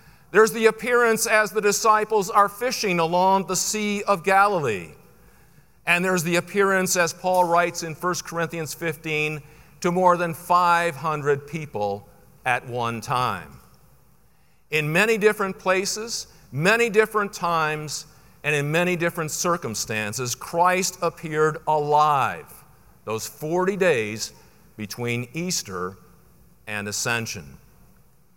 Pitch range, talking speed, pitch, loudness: 150-195 Hz, 115 wpm, 170 Hz, -22 LUFS